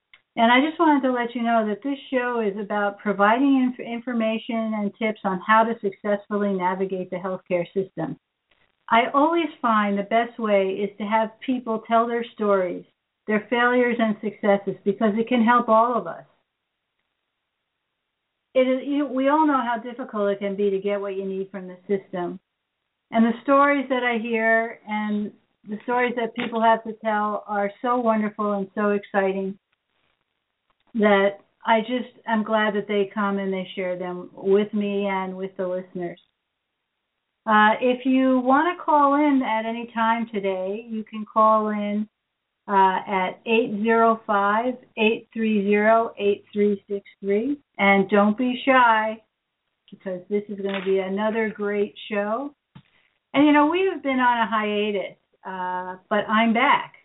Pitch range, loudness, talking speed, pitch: 200-235 Hz, -22 LUFS, 160 wpm, 215 Hz